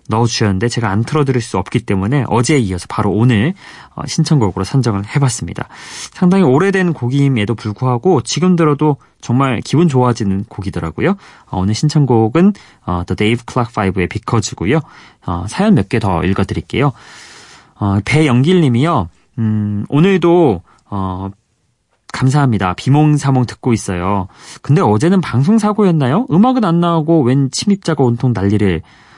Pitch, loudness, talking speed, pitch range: 125 Hz, -14 LUFS, 340 characters per minute, 105-150 Hz